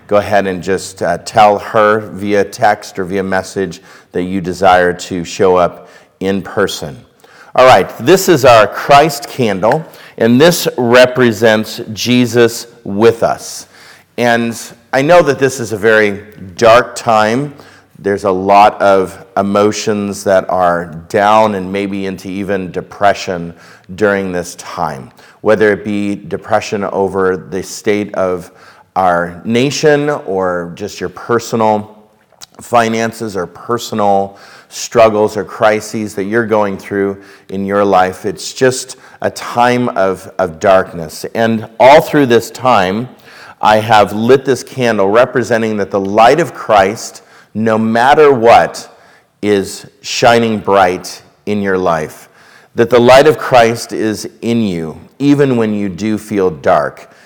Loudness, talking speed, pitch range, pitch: -12 LUFS, 140 wpm, 95-115 Hz, 105 Hz